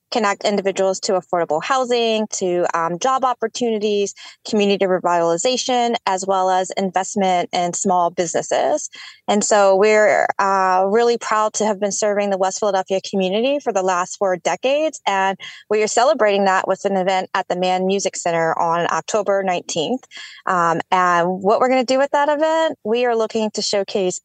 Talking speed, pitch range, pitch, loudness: 170 wpm, 185-235 Hz, 200 Hz, -18 LUFS